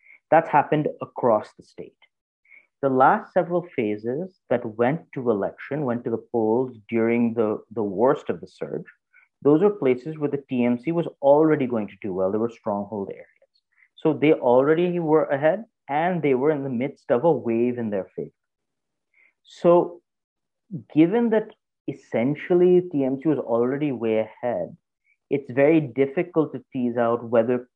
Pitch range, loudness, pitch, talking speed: 120-160 Hz, -23 LUFS, 135 Hz, 160 wpm